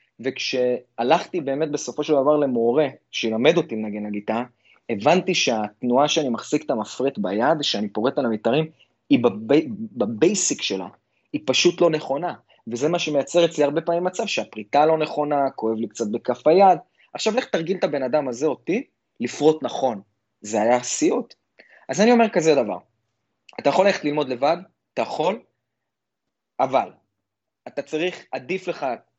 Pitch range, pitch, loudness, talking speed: 125-175 Hz, 150 Hz, -22 LUFS, 150 wpm